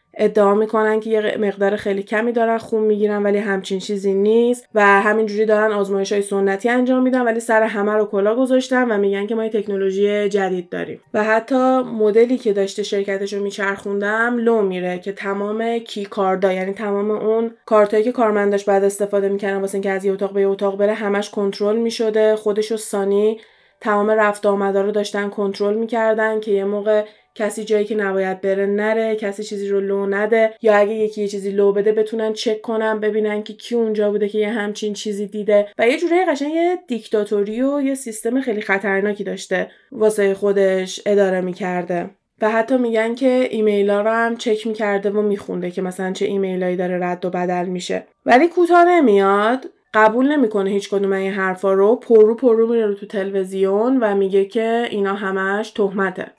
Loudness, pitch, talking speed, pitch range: -18 LUFS, 210 Hz, 185 wpm, 200-220 Hz